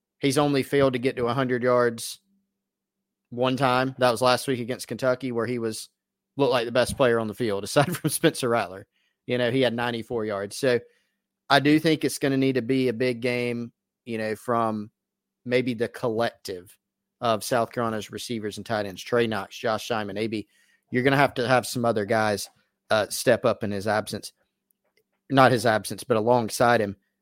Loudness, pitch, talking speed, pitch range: -25 LUFS, 120 Hz, 195 wpm, 110-130 Hz